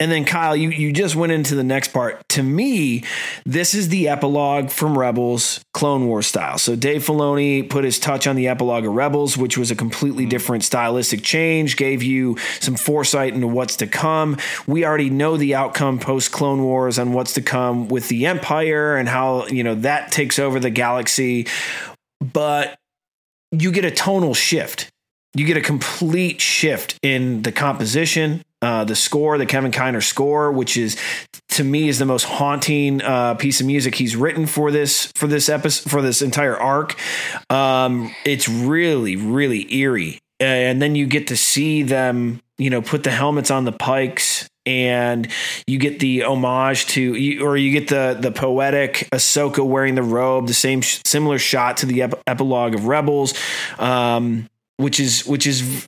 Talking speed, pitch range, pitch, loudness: 180 wpm, 125-145 Hz, 135 Hz, -18 LUFS